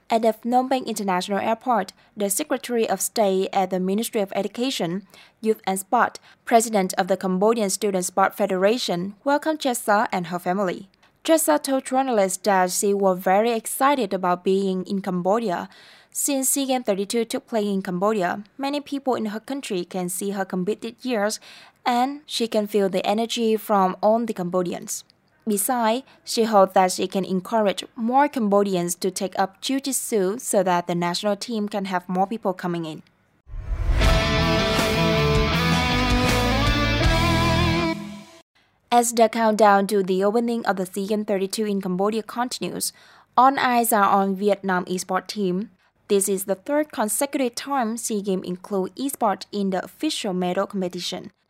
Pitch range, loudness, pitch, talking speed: 185-230 Hz, -22 LUFS, 200 Hz, 150 wpm